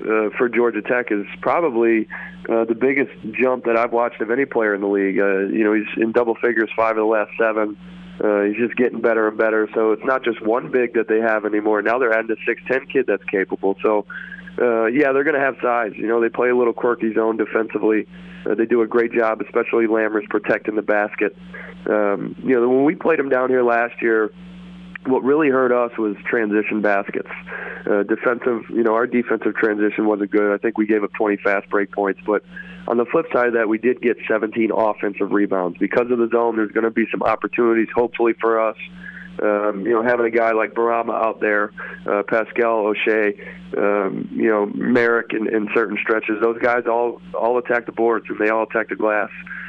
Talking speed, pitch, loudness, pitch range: 215 wpm, 115 Hz, -19 LUFS, 105-120 Hz